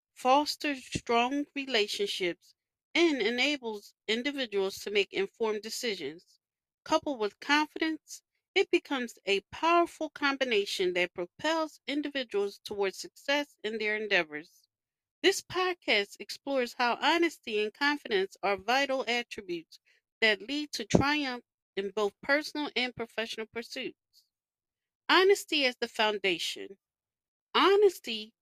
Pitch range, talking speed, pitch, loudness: 215-315 Hz, 110 wpm, 265 Hz, -30 LUFS